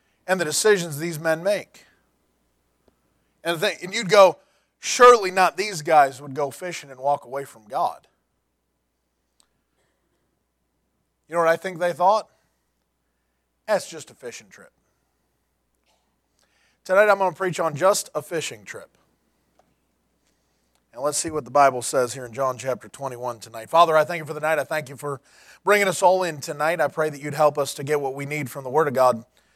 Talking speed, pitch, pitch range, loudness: 185 wpm, 150 Hz, 120-175 Hz, -22 LUFS